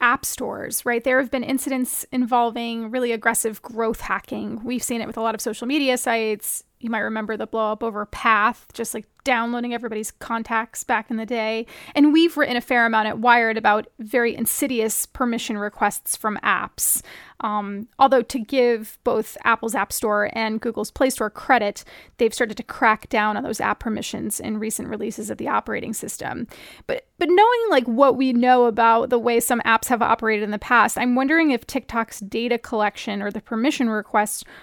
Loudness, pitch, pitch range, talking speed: -21 LUFS, 230 Hz, 220-250 Hz, 190 wpm